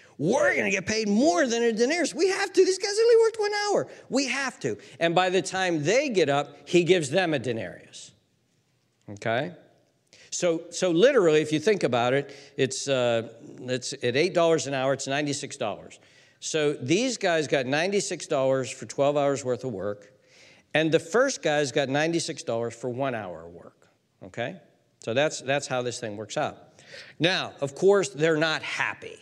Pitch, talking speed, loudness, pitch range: 150 Hz, 180 wpm, -25 LUFS, 130-190 Hz